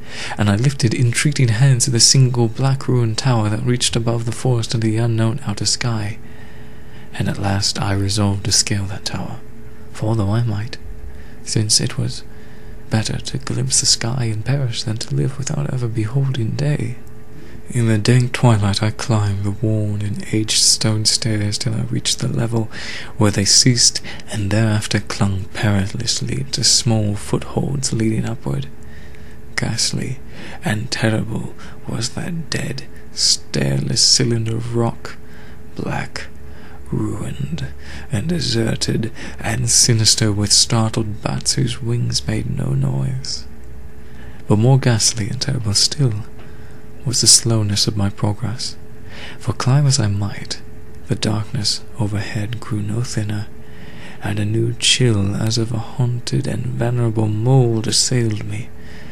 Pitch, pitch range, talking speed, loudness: 110 Hz, 105-120 Hz, 140 wpm, -18 LUFS